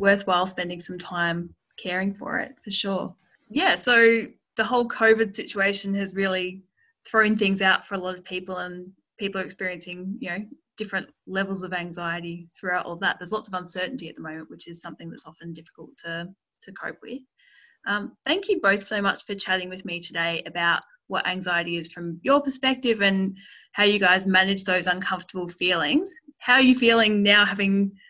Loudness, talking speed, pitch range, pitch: -23 LUFS, 185 wpm, 180-220 Hz, 195 Hz